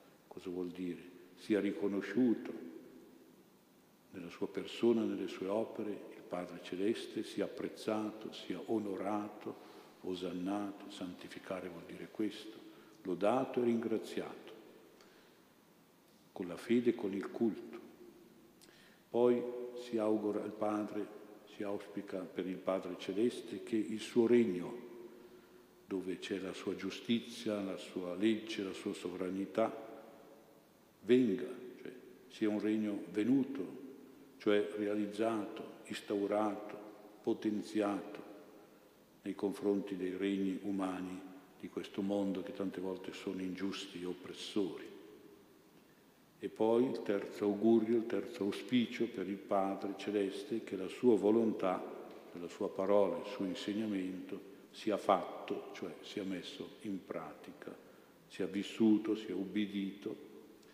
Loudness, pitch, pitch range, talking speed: -38 LUFS, 105 Hz, 95-110 Hz, 115 wpm